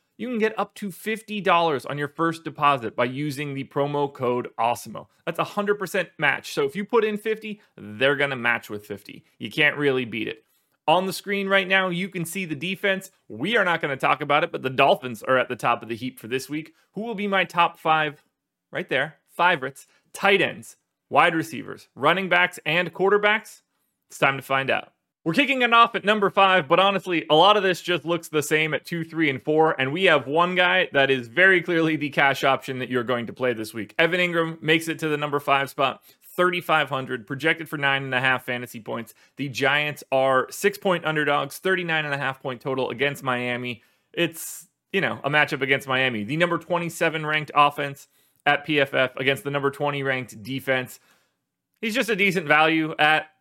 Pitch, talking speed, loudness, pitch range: 150 Hz, 210 wpm, -22 LUFS, 135-180 Hz